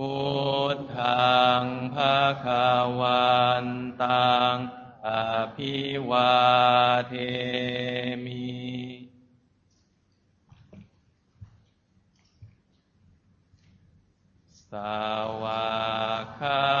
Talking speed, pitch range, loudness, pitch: 95 characters per minute, 105-125 Hz, -25 LUFS, 125 Hz